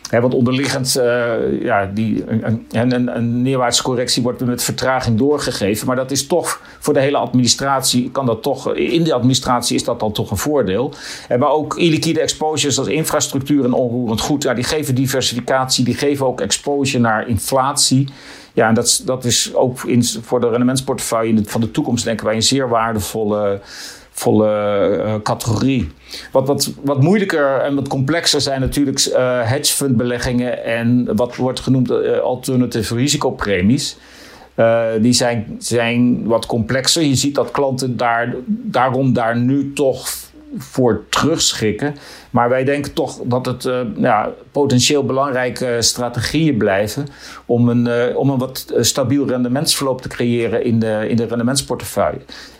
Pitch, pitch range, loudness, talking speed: 125 Hz, 120-140 Hz, -16 LUFS, 155 wpm